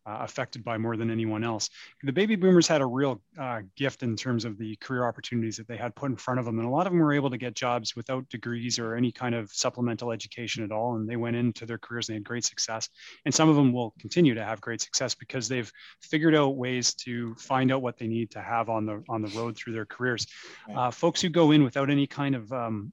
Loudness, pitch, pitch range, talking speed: -28 LUFS, 120 Hz, 115-130 Hz, 265 wpm